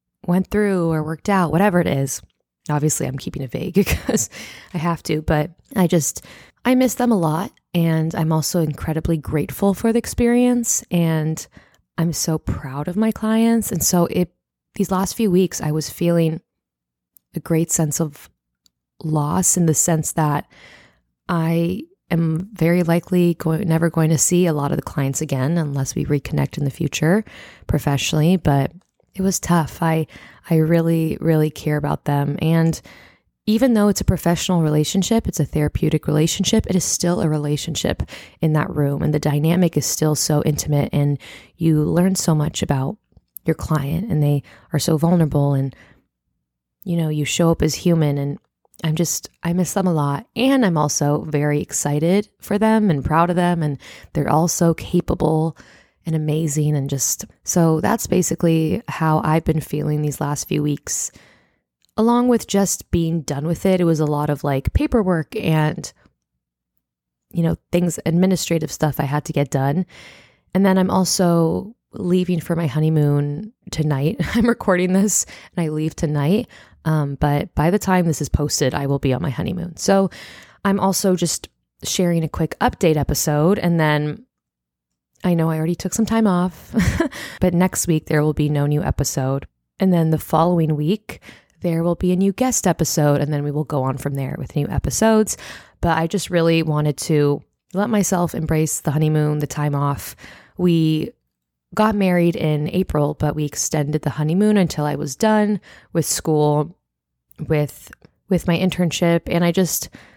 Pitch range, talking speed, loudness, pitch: 150-180 Hz, 175 wpm, -19 LUFS, 160 Hz